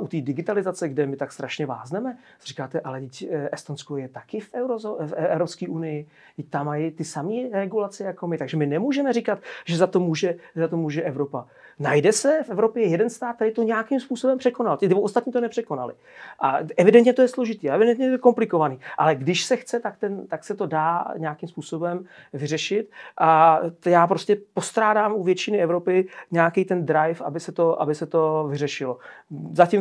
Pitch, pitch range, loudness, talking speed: 175 Hz, 155-215 Hz, -23 LUFS, 175 wpm